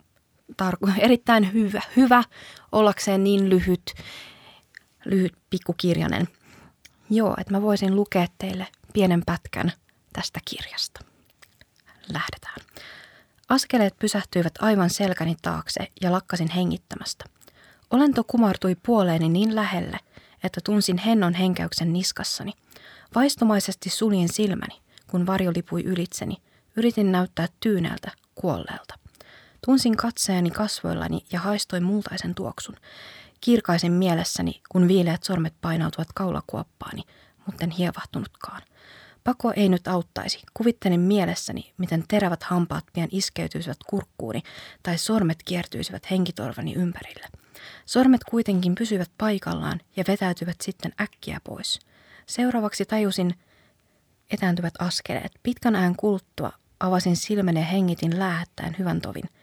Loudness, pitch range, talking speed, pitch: -24 LUFS, 175-210 Hz, 105 wpm, 190 Hz